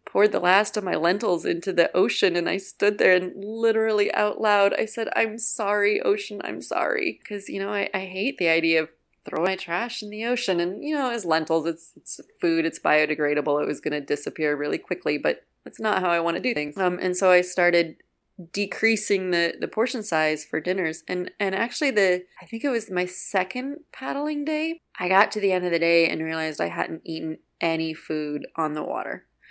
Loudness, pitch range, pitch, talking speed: -24 LUFS, 165-210 Hz, 185 Hz, 215 wpm